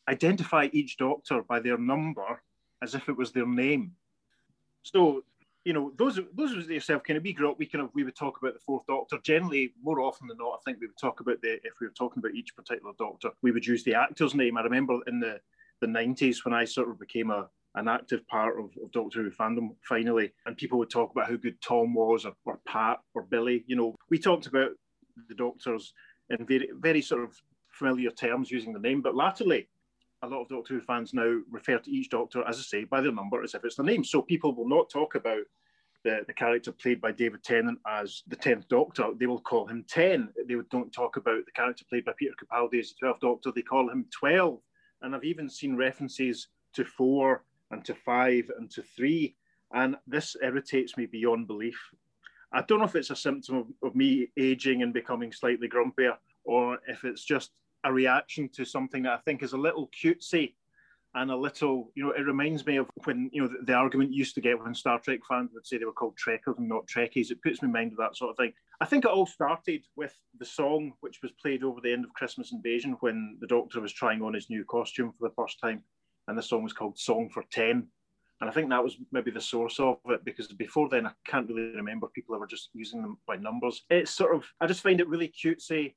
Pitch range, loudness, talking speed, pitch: 120-155 Hz, -30 LUFS, 235 wpm, 130 Hz